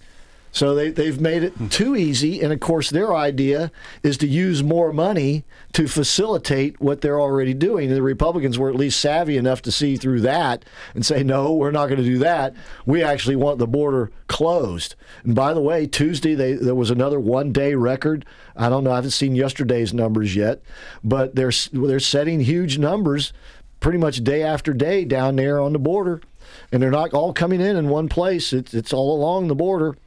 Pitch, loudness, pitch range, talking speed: 140 Hz, -20 LUFS, 130-155 Hz, 205 wpm